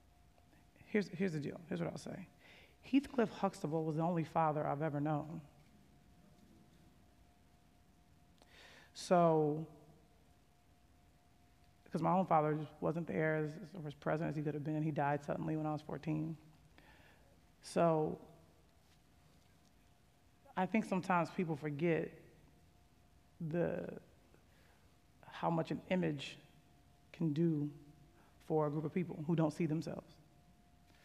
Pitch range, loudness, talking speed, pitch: 145-165 Hz, -38 LUFS, 120 wpm, 155 Hz